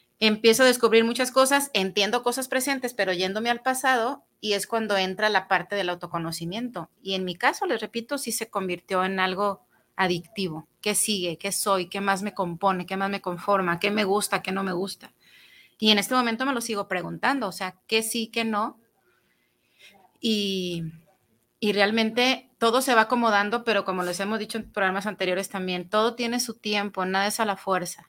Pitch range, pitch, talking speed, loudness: 190-230 Hz, 205 Hz, 190 wpm, -25 LUFS